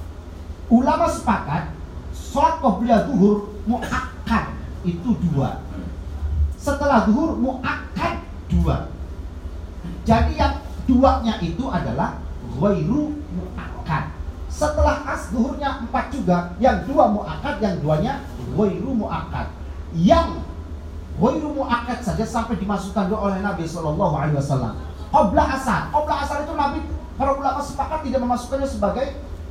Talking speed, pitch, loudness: 105 wpm, 200 Hz, -22 LUFS